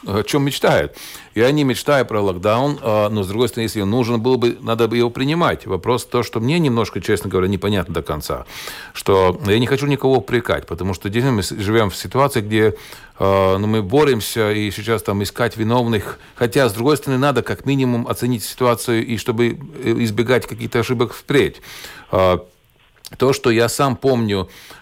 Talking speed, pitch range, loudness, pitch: 175 wpm, 105-125 Hz, -18 LUFS, 115 Hz